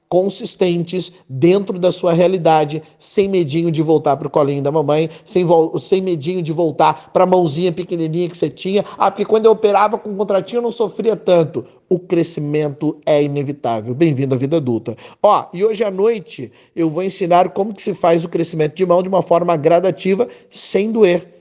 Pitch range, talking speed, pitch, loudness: 155-190 Hz, 185 wpm, 175 Hz, -16 LUFS